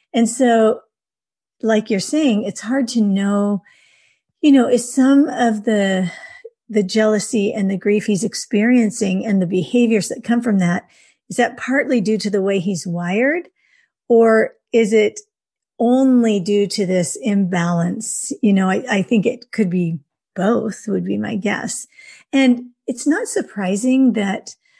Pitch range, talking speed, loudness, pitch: 200-255 Hz, 155 wpm, -17 LUFS, 220 Hz